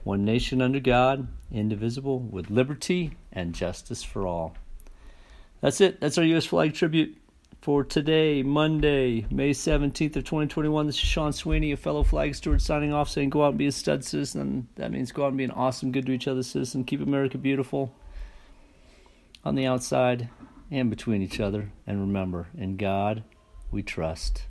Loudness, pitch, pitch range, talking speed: -27 LUFS, 125 Hz, 95-145 Hz, 175 wpm